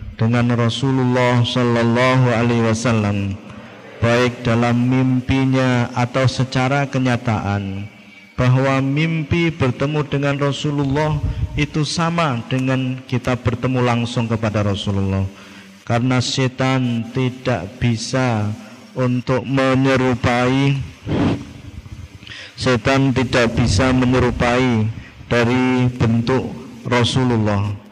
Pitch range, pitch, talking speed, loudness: 115-130 Hz, 125 Hz, 80 wpm, -18 LUFS